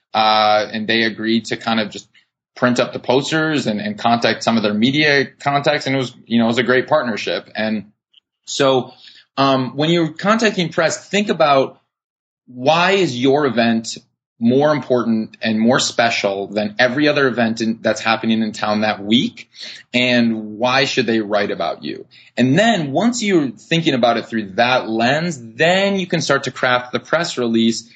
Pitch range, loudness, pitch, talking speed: 110-145 Hz, -17 LUFS, 125 Hz, 180 wpm